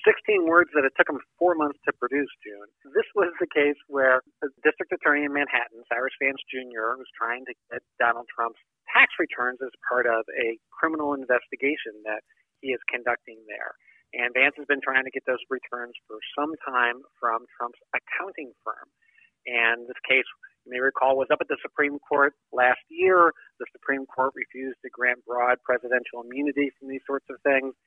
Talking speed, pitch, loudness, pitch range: 185 wpm, 135 Hz, -25 LUFS, 125-145 Hz